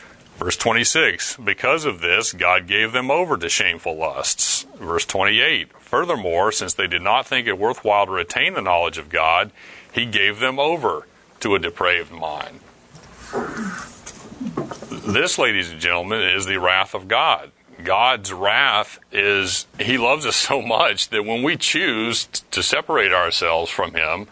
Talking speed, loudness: 155 wpm, -19 LUFS